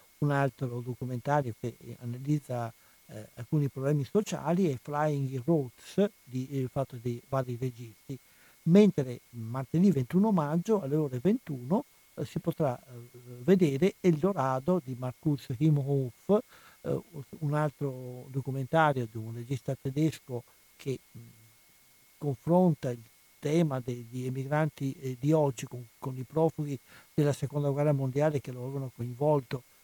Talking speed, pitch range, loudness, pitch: 130 wpm, 125-155 Hz, -30 LUFS, 140 Hz